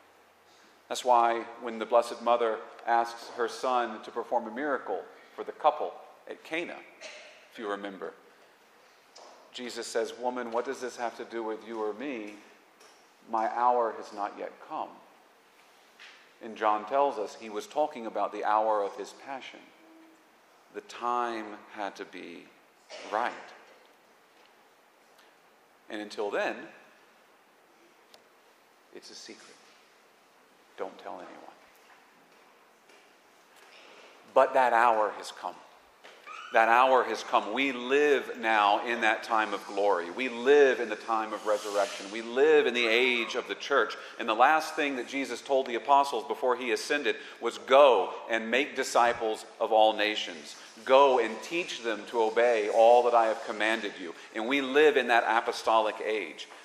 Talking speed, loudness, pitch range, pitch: 145 wpm, -28 LUFS, 110-130 Hz, 115 Hz